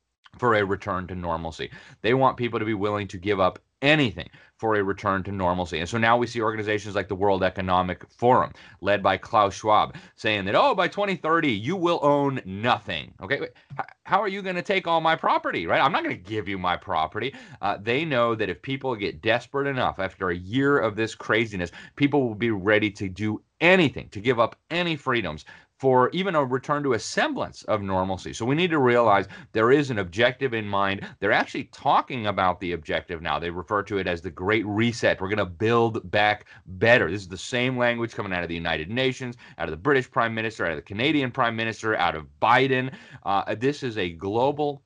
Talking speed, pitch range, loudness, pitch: 215 wpm, 95-130 Hz, -24 LUFS, 110 Hz